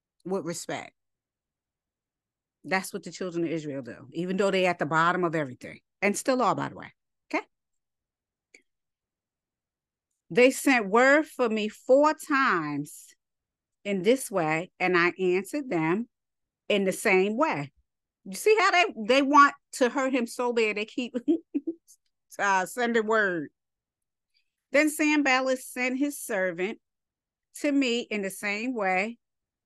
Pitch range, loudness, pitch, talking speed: 175-260 Hz, -26 LUFS, 205 Hz, 145 wpm